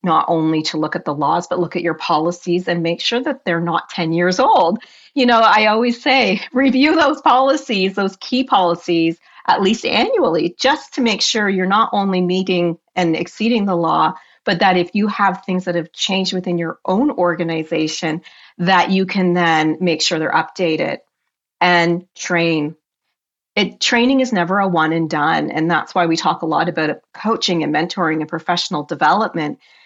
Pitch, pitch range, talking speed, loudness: 175 Hz, 165-210 Hz, 185 wpm, -17 LUFS